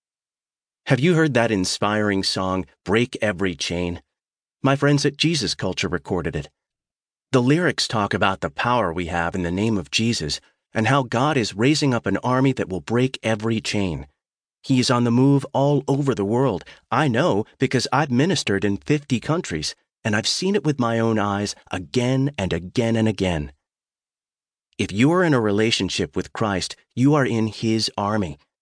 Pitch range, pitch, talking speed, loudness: 95-135 Hz, 110 Hz, 180 wpm, -21 LUFS